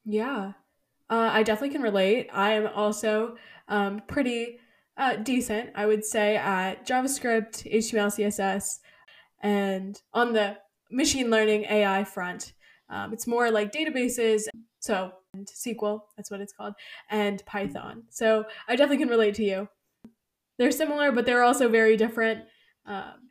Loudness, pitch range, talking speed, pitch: -26 LUFS, 205-240 Hz, 145 wpm, 220 Hz